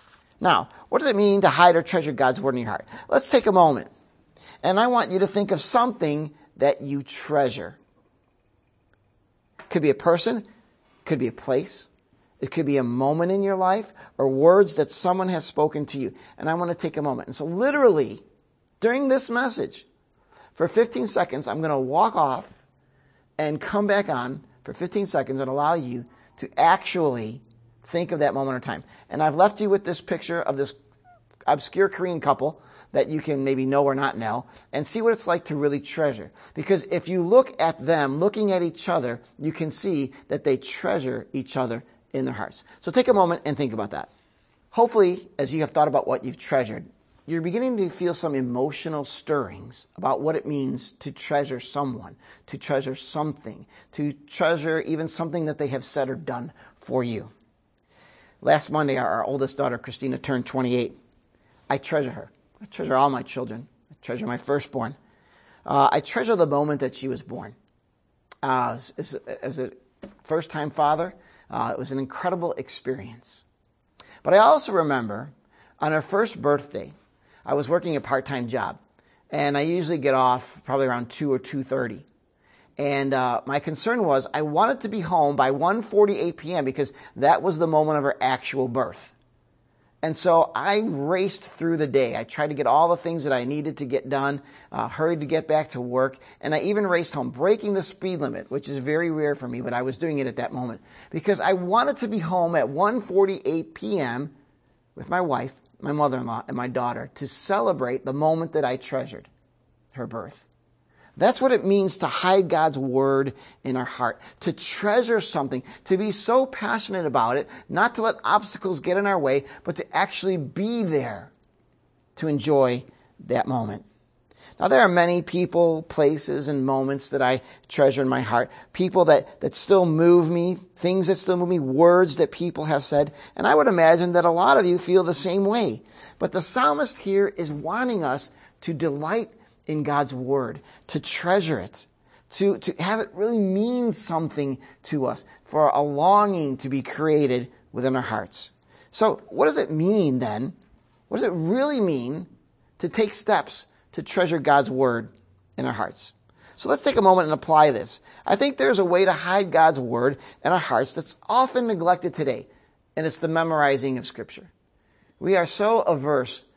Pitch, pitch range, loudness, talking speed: 150 Hz, 135-180 Hz, -23 LUFS, 185 wpm